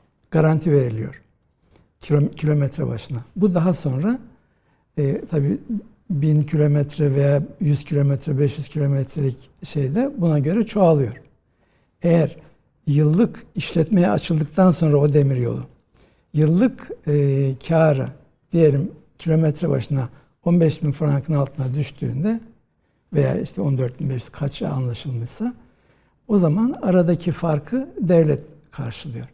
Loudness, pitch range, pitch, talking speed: -20 LUFS, 140-170 Hz, 150 Hz, 110 wpm